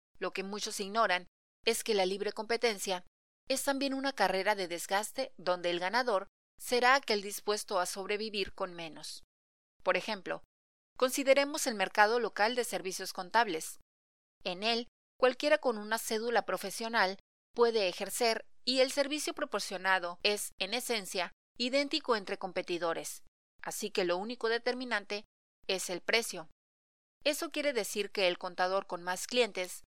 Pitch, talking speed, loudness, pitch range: 205 Hz, 140 wpm, -33 LUFS, 185-240 Hz